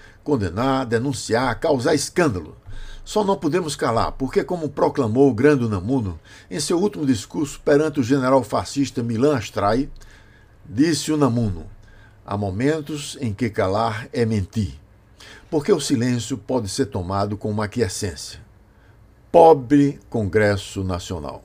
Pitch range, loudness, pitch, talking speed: 105-140 Hz, -21 LUFS, 115 Hz, 125 wpm